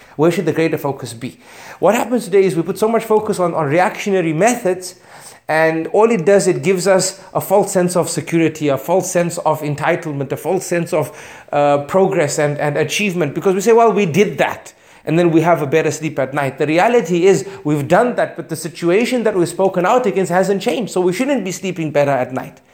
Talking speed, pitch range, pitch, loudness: 225 wpm, 155-195 Hz, 175 Hz, -16 LUFS